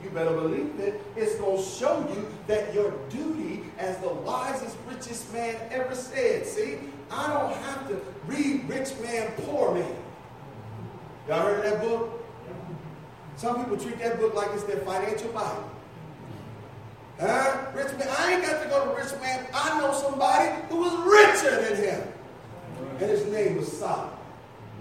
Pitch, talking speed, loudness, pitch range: 230 Hz, 165 wpm, -27 LUFS, 190-275 Hz